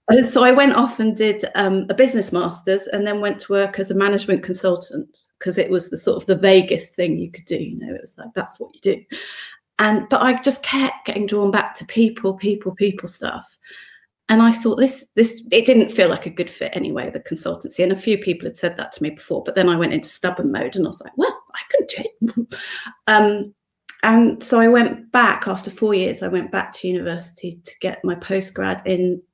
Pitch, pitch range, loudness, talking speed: 205 Hz, 185-235 Hz, -19 LUFS, 235 wpm